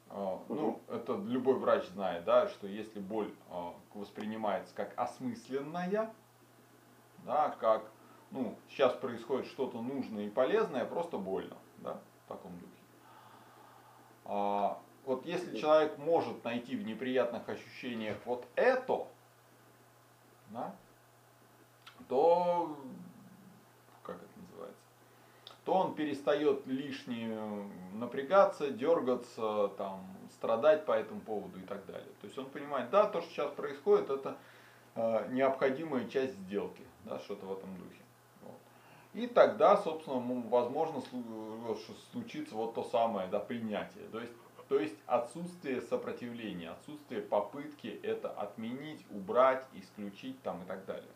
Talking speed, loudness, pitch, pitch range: 115 wpm, -35 LUFS, 130 Hz, 110-160 Hz